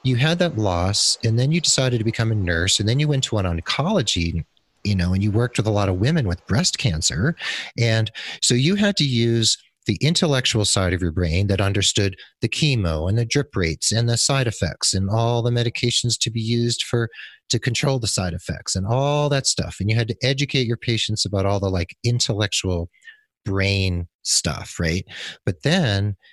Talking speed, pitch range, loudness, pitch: 205 wpm, 95-130 Hz, -21 LUFS, 115 Hz